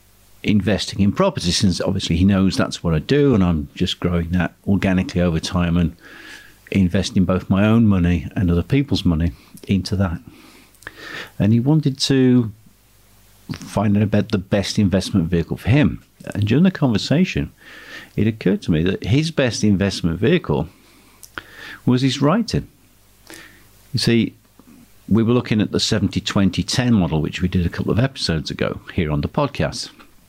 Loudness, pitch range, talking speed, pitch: -19 LUFS, 90-110 Hz, 160 wpm, 100 Hz